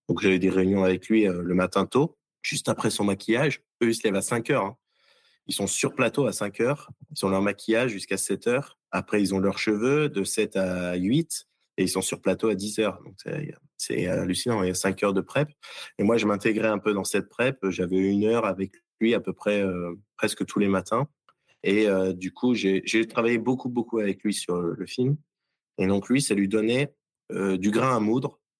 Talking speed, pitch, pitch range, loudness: 235 wpm, 105 Hz, 95-120 Hz, -25 LUFS